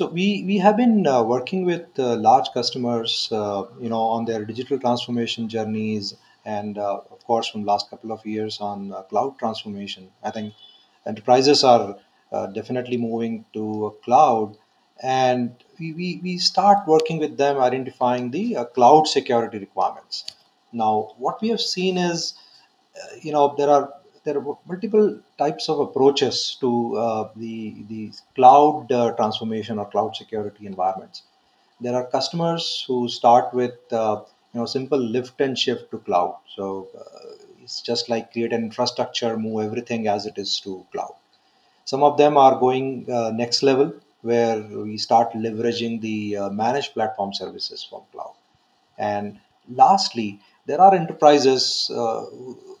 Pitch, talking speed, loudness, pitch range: 120 Hz, 160 wpm, -21 LUFS, 110-145 Hz